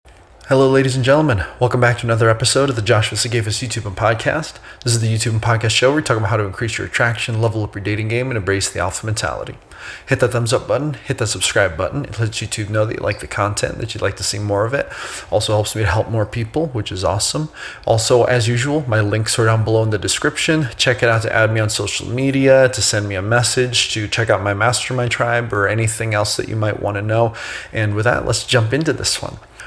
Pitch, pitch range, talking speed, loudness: 115 Hz, 105-125 Hz, 255 wpm, -17 LUFS